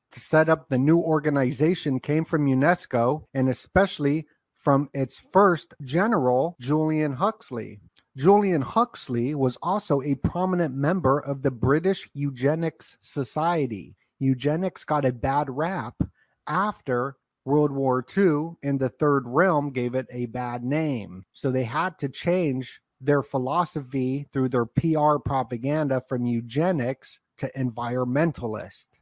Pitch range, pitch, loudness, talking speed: 130-160 Hz, 140 Hz, -25 LUFS, 125 wpm